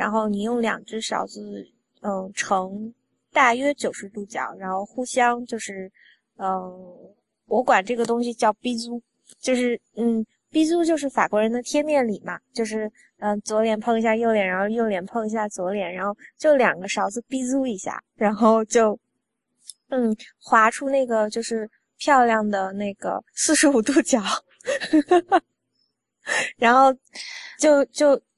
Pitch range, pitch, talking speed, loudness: 210-260 Hz, 230 Hz, 220 characters per minute, -22 LUFS